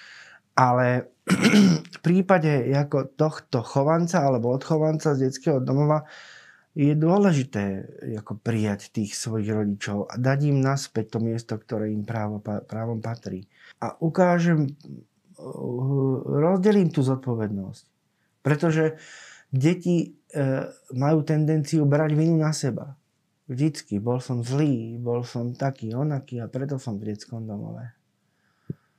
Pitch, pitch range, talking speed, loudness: 135 Hz, 115-155 Hz, 115 wpm, -24 LUFS